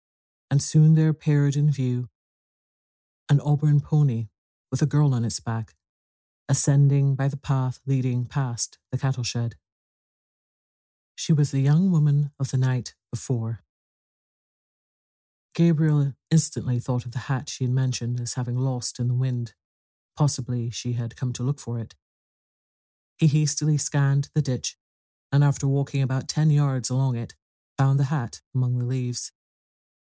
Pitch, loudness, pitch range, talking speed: 130 Hz, -24 LUFS, 120-145 Hz, 150 wpm